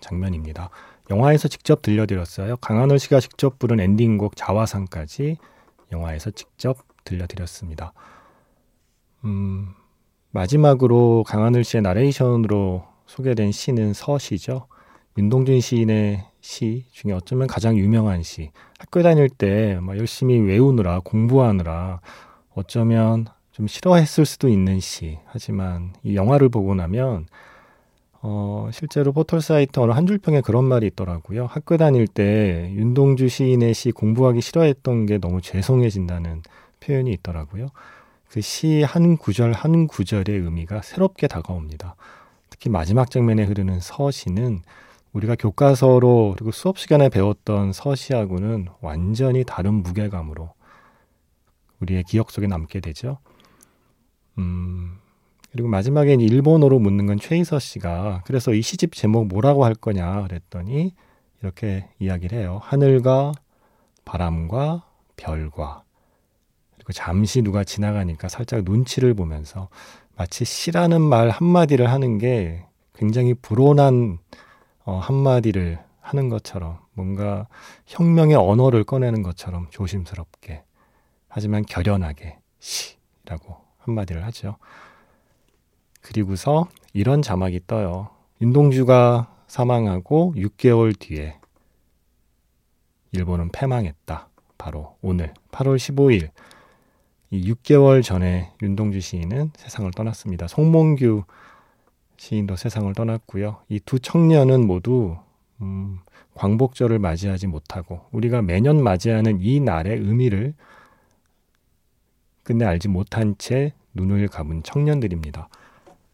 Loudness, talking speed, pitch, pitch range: -20 LUFS, 270 characters per minute, 110 Hz, 95-130 Hz